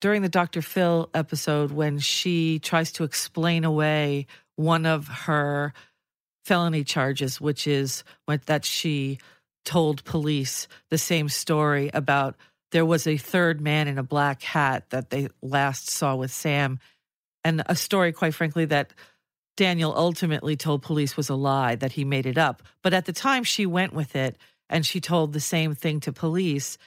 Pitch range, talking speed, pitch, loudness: 140-165 Hz, 165 wpm, 150 Hz, -25 LUFS